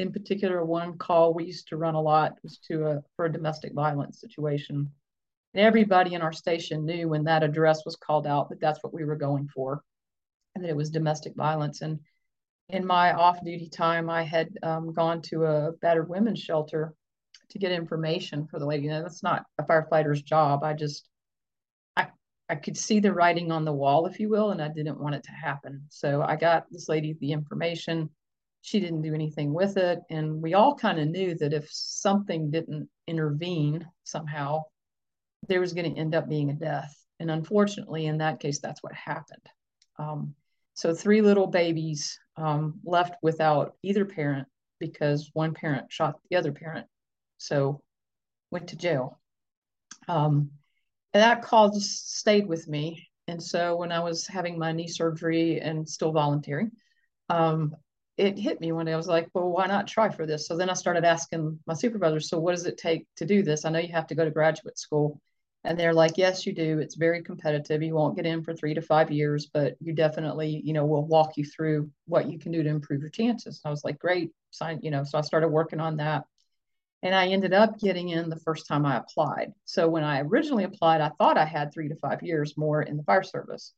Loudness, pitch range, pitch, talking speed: -27 LUFS, 150-175 Hz, 160 Hz, 210 wpm